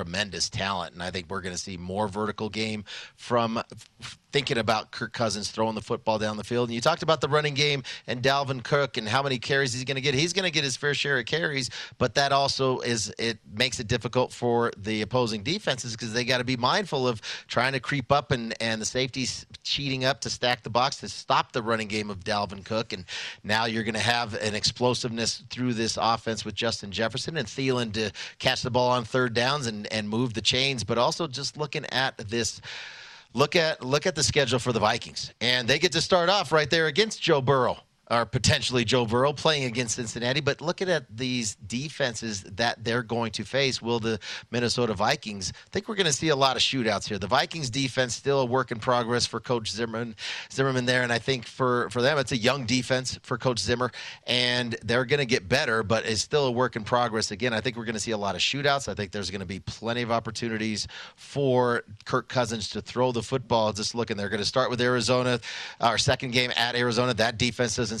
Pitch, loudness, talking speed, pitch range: 120 Hz, -26 LUFS, 225 wpm, 110-130 Hz